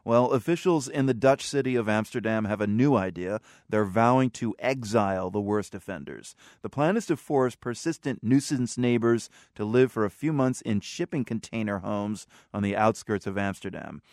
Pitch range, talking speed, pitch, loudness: 105-135 Hz, 180 wpm, 115 Hz, -27 LUFS